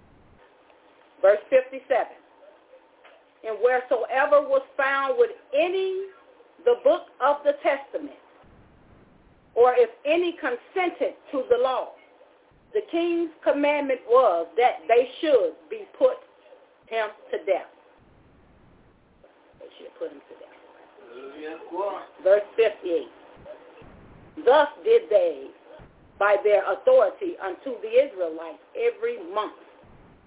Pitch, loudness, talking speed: 310 Hz, -24 LUFS, 100 wpm